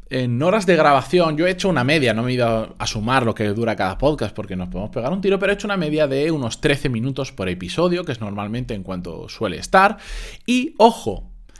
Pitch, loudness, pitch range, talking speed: 130 Hz, -20 LUFS, 105-175 Hz, 240 wpm